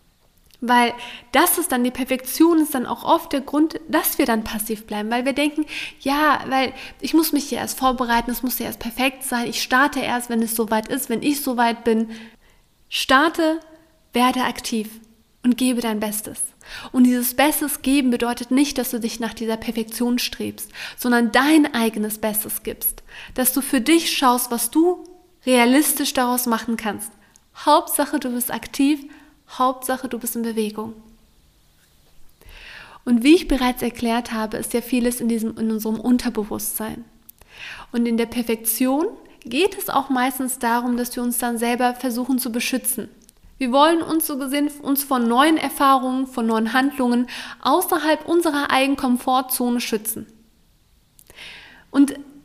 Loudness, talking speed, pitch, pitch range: -20 LUFS, 160 wpm, 255 Hz, 235-280 Hz